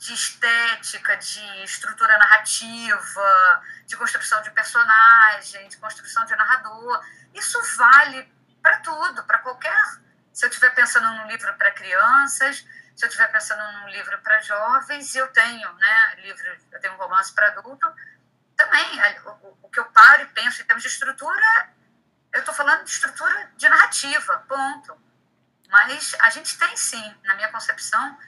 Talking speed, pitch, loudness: 155 wpm, 270 Hz, -17 LUFS